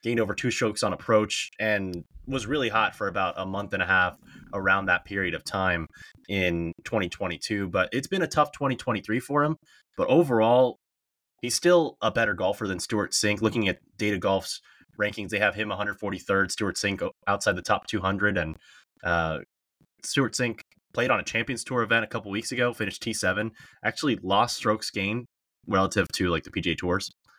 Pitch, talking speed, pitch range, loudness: 110 Hz, 180 wpm, 100-125 Hz, -26 LUFS